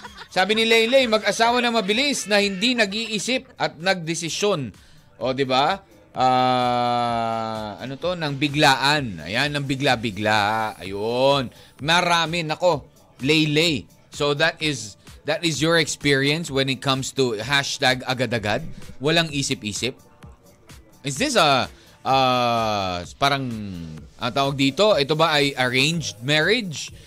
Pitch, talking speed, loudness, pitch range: 140 Hz, 120 wpm, -21 LUFS, 125-165 Hz